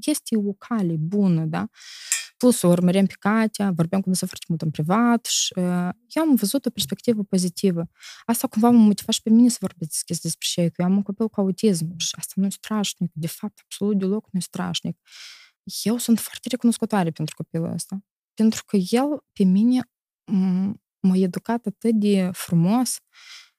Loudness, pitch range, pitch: -22 LUFS, 180-230 Hz, 200 Hz